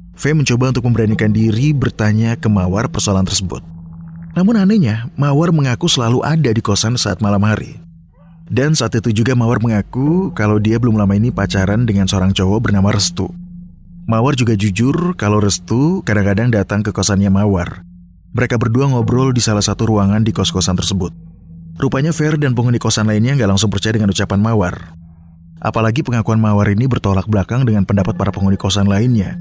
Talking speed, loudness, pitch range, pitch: 165 wpm, -15 LUFS, 100-125 Hz, 110 Hz